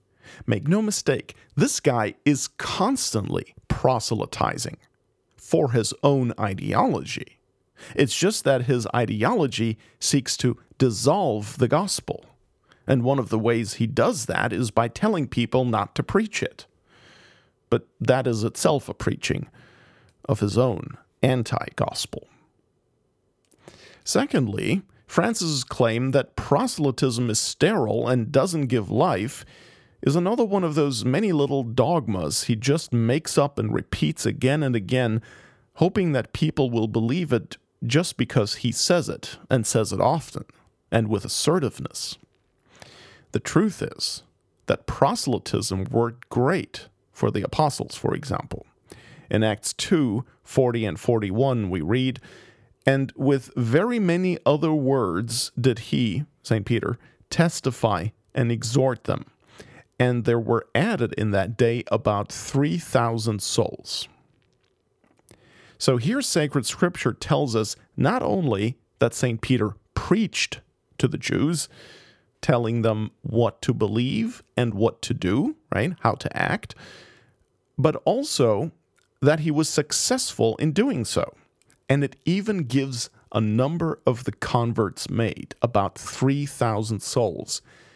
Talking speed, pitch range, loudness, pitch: 130 wpm, 115-145 Hz, -24 LUFS, 125 Hz